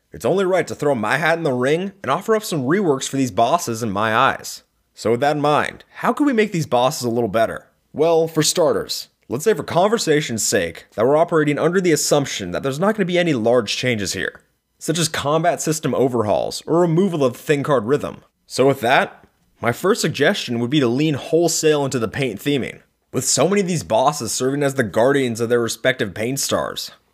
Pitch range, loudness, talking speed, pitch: 125-165 Hz, -19 LUFS, 220 wpm, 145 Hz